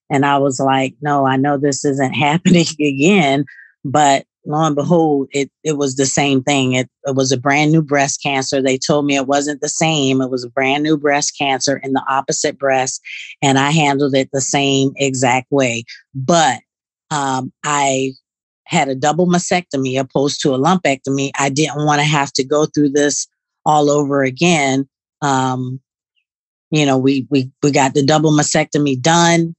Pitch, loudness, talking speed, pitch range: 140 Hz, -15 LUFS, 180 wpm, 135-150 Hz